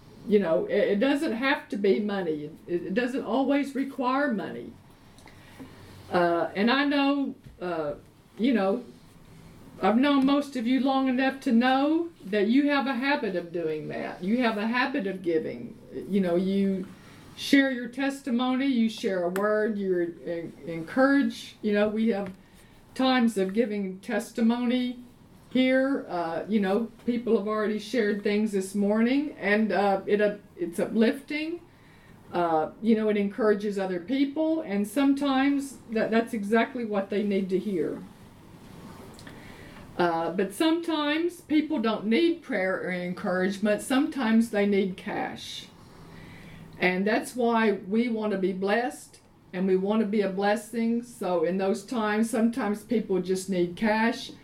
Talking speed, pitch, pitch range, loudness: 150 wpm, 215 Hz, 195-260 Hz, -26 LUFS